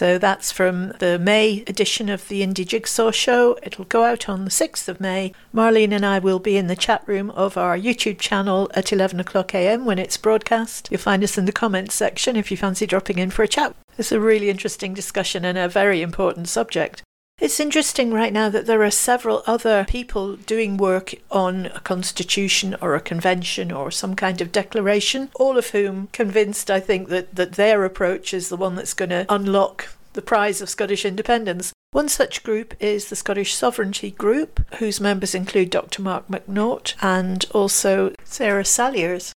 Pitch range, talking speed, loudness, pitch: 190-215 Hz, 195 wpm, -20 LUFS, 200 Hz